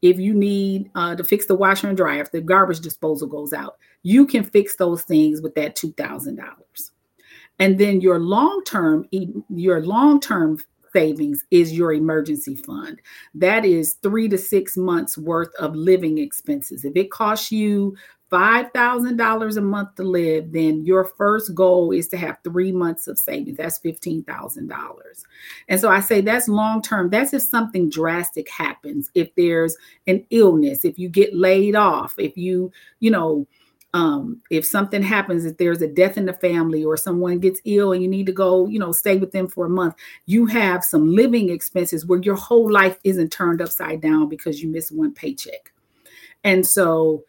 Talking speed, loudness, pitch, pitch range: 180 wpm, -19 LUFS, 185 Hz, 165-210 Hz